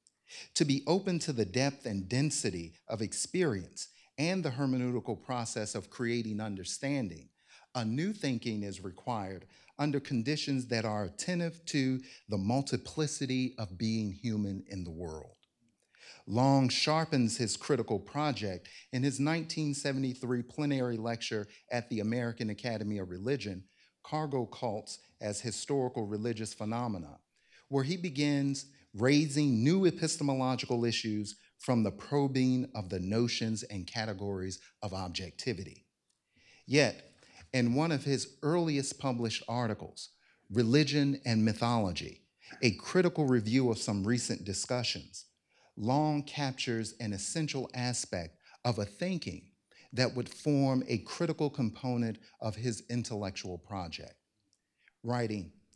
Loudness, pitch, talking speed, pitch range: -33 LUFS, 120 Hz, 120 wpm, 105-140 Hz